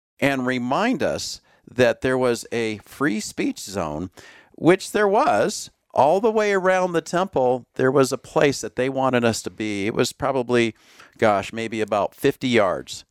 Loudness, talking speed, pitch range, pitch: -22 LUFS, 170 wpm, 110-155 Hz, 130 Hz